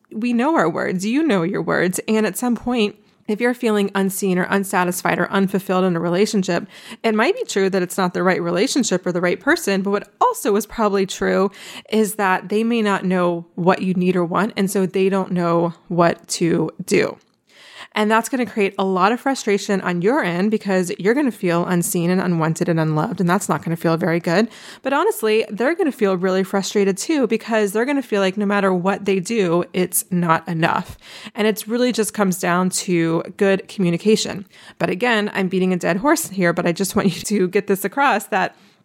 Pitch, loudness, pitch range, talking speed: 195 Hz, -19 LUFS, 180-215 Hz, 220 wpm